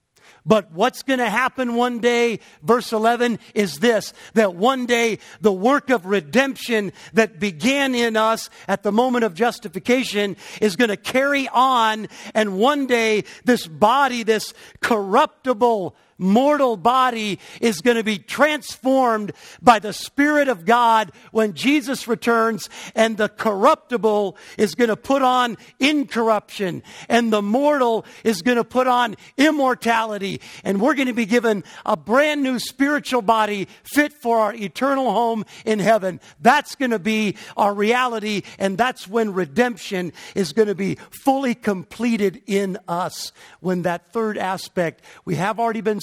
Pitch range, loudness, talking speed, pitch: 205-250 Hz, -20 LUFS, 150 wpm, 225 Hz